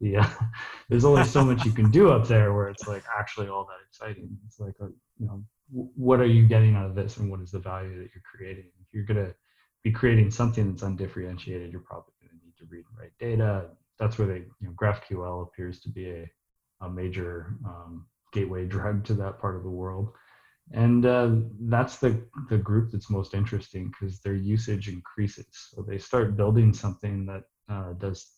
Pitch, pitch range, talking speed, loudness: 105 Hz, 95-115 Hz, 205 wpm, -26 LUFS